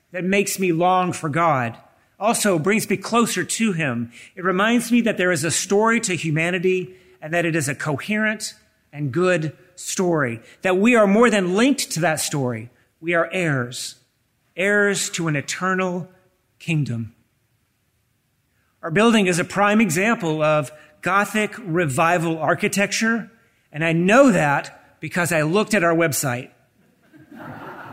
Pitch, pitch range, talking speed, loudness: 175 Hz, 150-200 Hz, 145 wpm, -20 LUFS